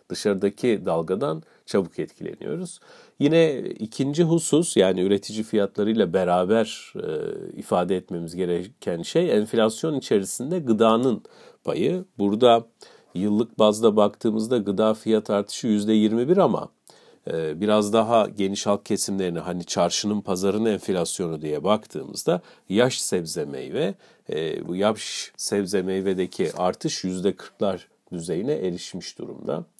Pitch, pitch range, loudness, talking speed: 105 Hz, 95-115 Hz, -24 LUFS, 110 wpm